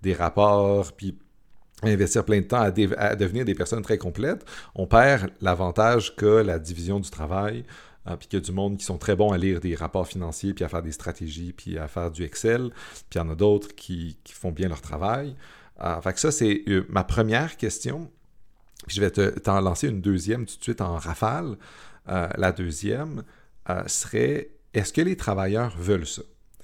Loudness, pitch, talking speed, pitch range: -25 LUFS, 100 Hz, 205 wpm, 90-110 Hz